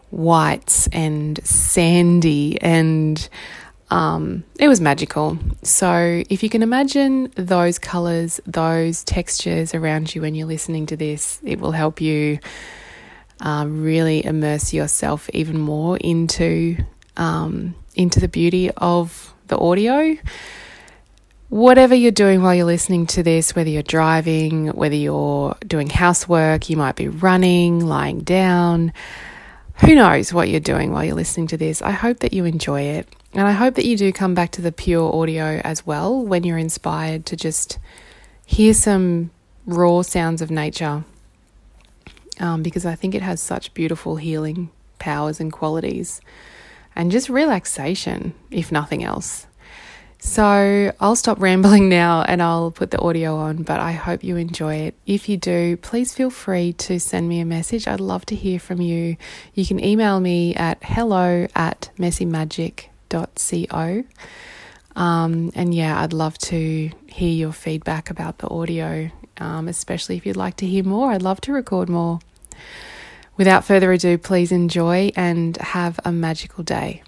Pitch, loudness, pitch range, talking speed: 170 Hz, -18 LUFS, 160-185 Hz, 155 wpm